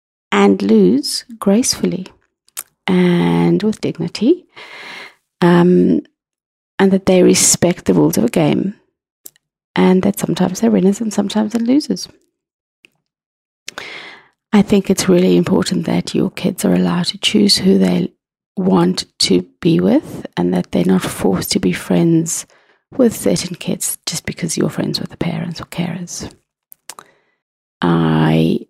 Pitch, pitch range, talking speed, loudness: 185 Hz, 170-215 Hz, 135 wpm, -15 LUFS